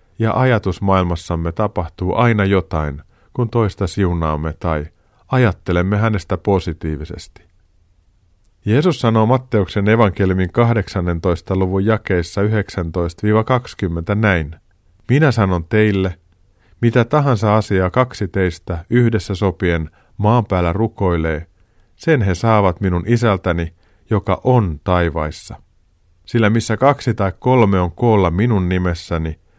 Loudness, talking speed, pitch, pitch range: -17 LUFS, 105 wpm, 95 Hz, 85-110 Hz